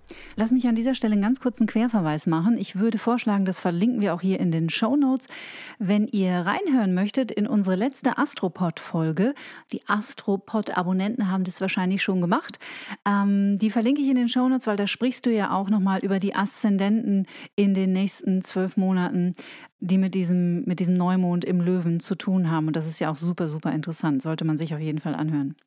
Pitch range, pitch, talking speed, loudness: 180-225 Hz, 195 Hz, 210 wpm, -24 LUFS